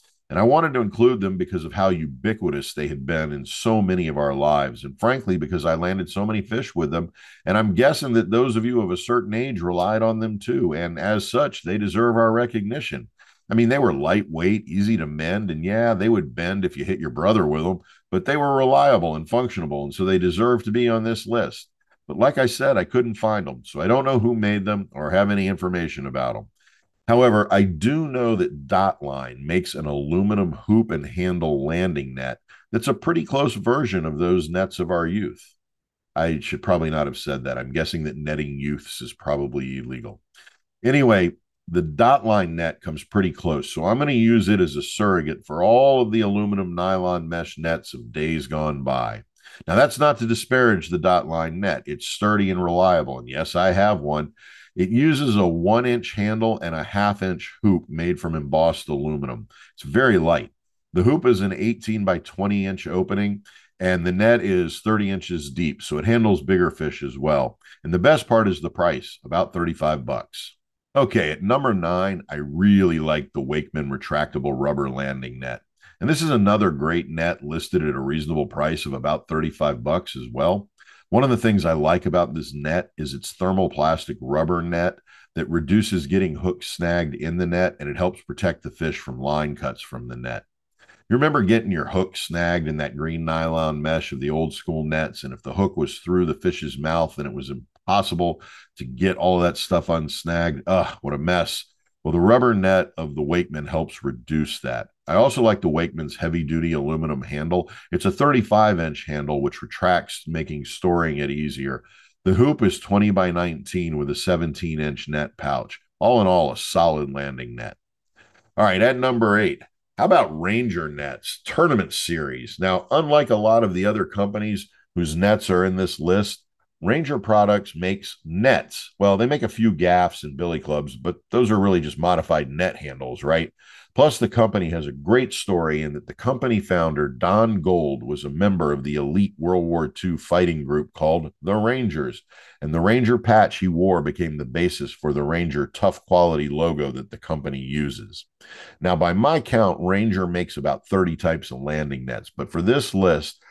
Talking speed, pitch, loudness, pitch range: 195 wpm, 90 Hz, -22 LUFS, 75-105 Hz